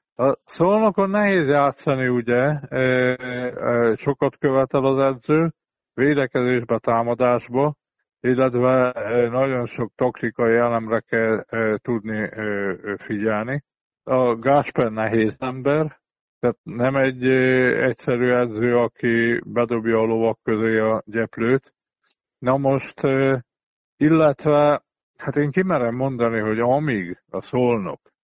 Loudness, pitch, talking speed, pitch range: -21 LUFS, 125 Hz, 100 wpm, 115-135 Hz